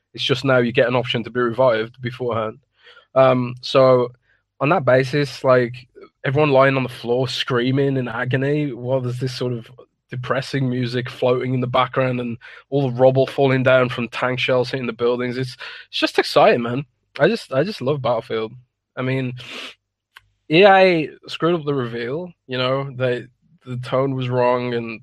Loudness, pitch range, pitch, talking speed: -19 LUFS, 120-135 Hz, 125 Hz, 175 wpm